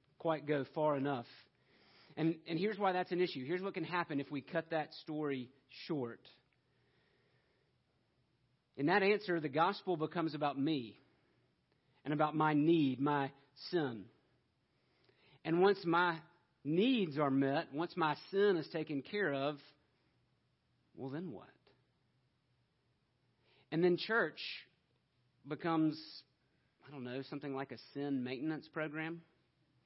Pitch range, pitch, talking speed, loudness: 135-165 Hz, 150 Hz, 130 wpm, -37 LUFS